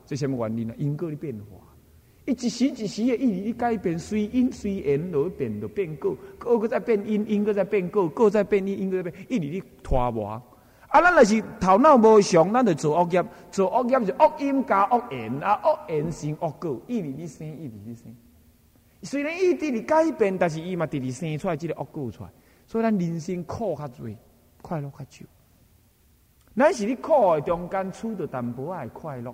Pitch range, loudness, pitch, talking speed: 135-220 Hz, -24 LUFS, 180 Hz, 285 characters per minute